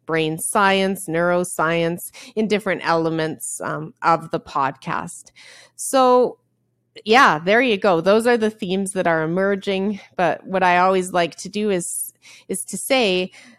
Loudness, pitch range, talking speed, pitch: -19 LUFS, 165-210 Hz, 145 wpm, 190 Hz